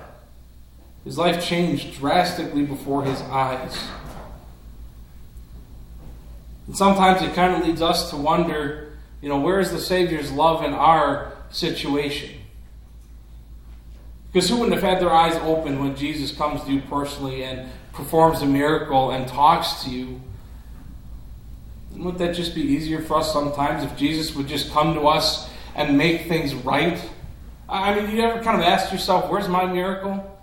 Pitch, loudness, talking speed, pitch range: 150 Hz, -21 LUFS, 155 wpm, 130-170 Hz